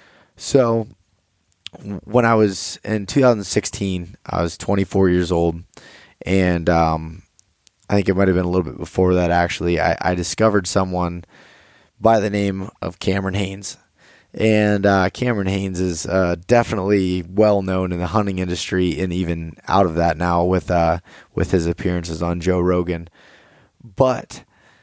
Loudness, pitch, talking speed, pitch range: -19 LUFS, 95 Hz, 150 wpm, 85-100 Hz